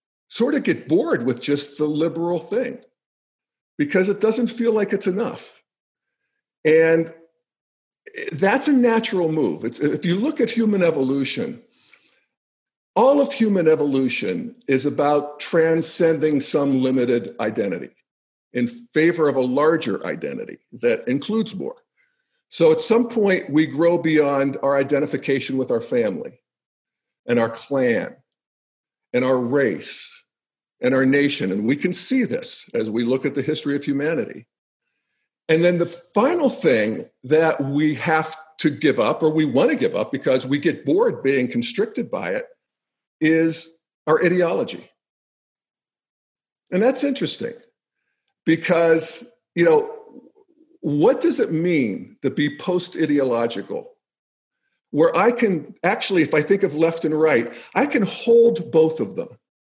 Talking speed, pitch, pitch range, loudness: 140 wpm, 165 Hz, 145-235 Hz, -20 LUFS